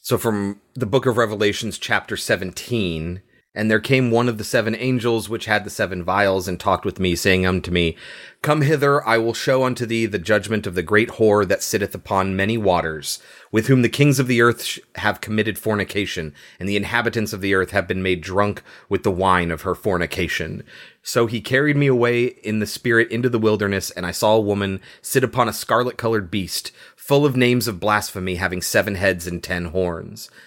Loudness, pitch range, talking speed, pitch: -20 LUFS, 95-115 Hz, 210 wpm, 105 Hz